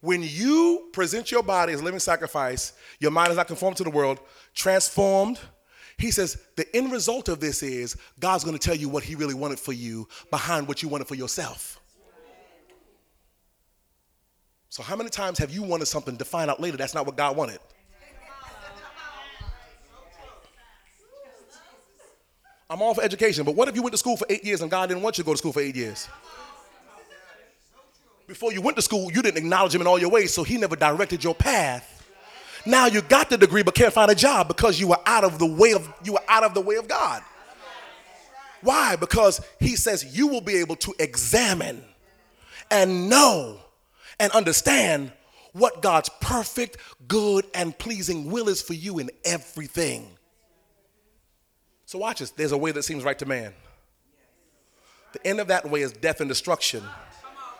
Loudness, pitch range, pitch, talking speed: -23 LUFS, 150-215 Hz, 180 Hz, 175 wpm